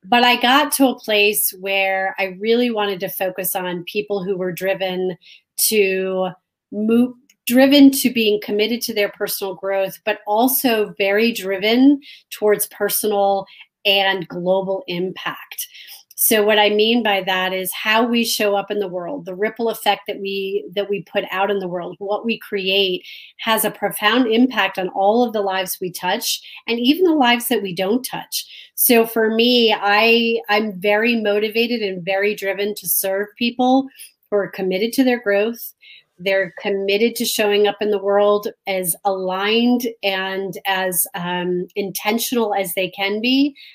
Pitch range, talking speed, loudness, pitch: 195-230 Hz, 165 wpm, -18 LUFS, 205 Hz